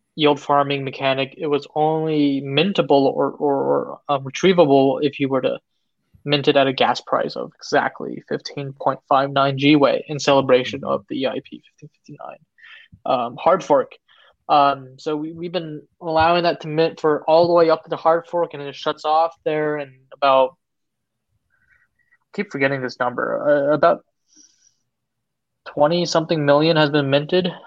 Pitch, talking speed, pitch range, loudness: 150 Hz, 170 wpm, 140-165 Hz, -19 LUFS